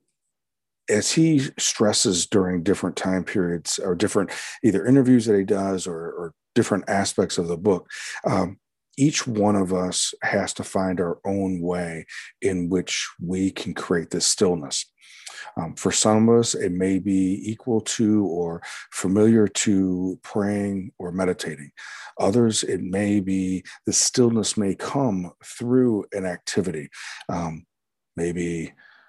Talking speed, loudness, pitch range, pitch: 140 wpm, -23 LUFS, 90-110 Hz, 95 Hz